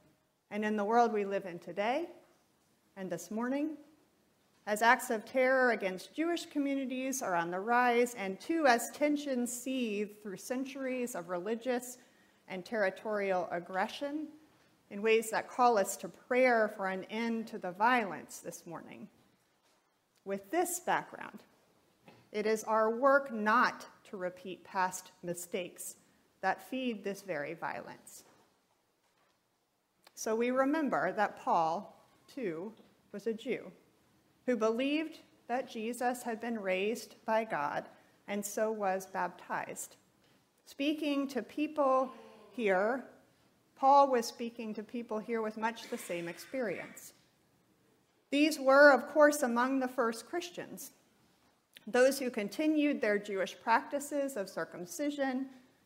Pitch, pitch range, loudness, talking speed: 230 Hz, 200-265 Hz, -33 LUFS, 130 wpm